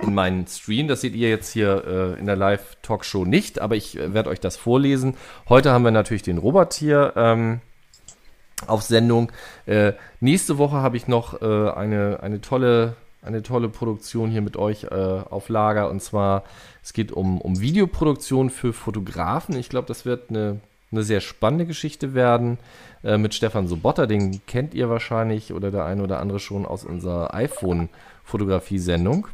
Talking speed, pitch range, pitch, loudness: 175 wpm, 100-125 Hz, 110 Hz, -22 LUFS